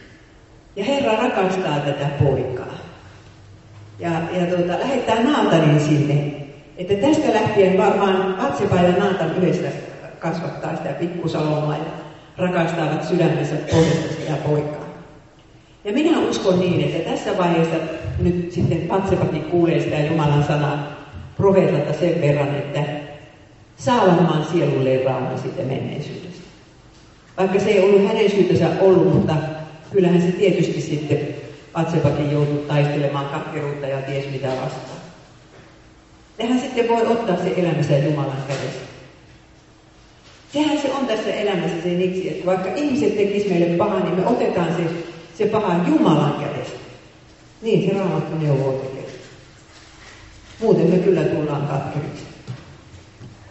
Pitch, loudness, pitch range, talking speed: 160 Hz, -20 LUFS, 145-185 Hz, 125 wpm